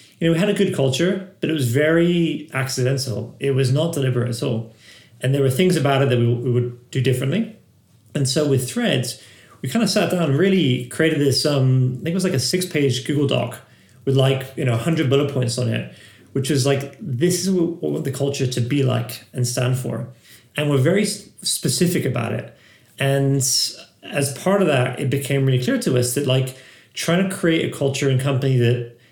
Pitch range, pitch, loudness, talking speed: 125-160 Hz, 135 Hz, -20 LUFS, 220 wpm